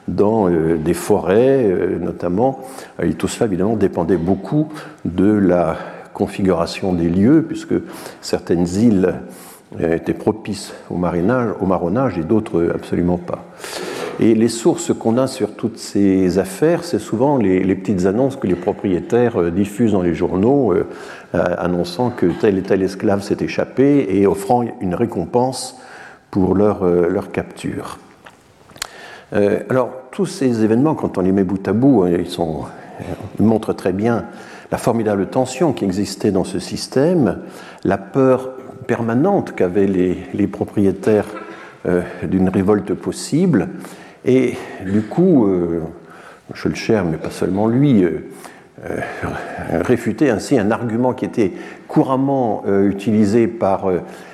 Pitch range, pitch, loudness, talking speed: 95-125 Hz, 105 Hz, -18 LUFS, 140 wpm